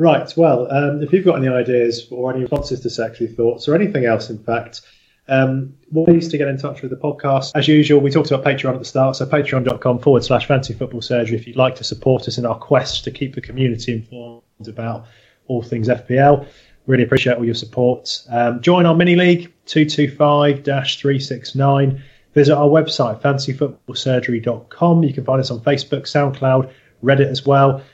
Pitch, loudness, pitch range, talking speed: 130 Hz, -17 LUFS, 120-145 Hz, 195 wpm